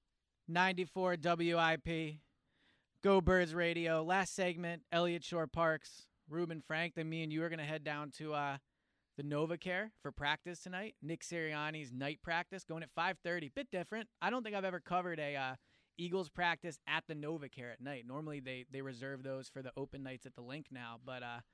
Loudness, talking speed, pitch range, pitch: -39 LUFS, 190 wpm, 145-175 Hz, 160 Hz